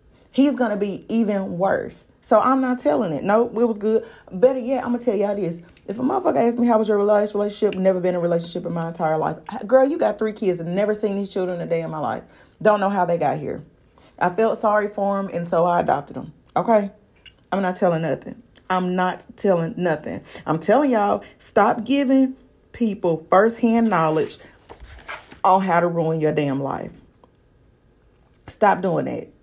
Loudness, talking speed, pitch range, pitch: -21 LUFS, 200 wpm, 175-230 Hz, 200 Hz